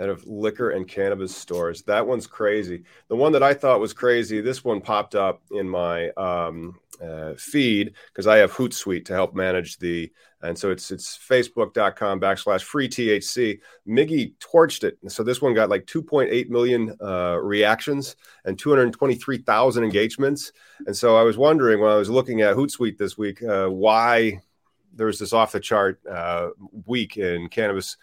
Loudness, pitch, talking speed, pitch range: -22 LUFS, 105 Hz, 175 wpm, 90-120 Hz